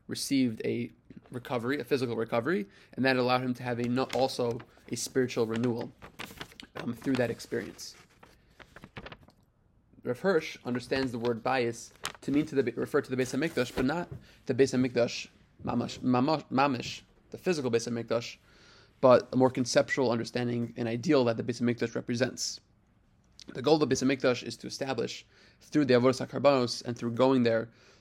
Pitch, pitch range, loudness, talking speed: 125 Hz, 120-130 Hz, -30 LUFS, 165 wpm